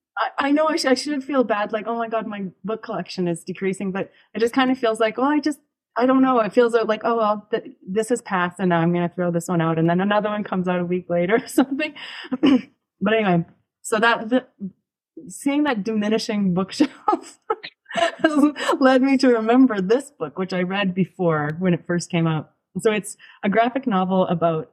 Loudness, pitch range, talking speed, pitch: -21 LUFS, 185-260 Hz, 215 wpm, 220 Hz